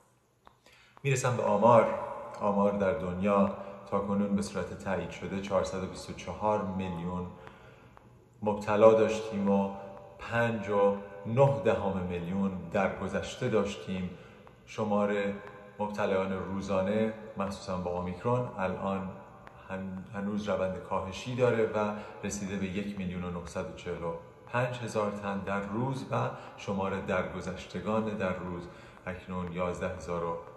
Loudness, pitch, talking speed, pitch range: -31 LUFS, 100 Hz, 100 wpm, 95-105 Hz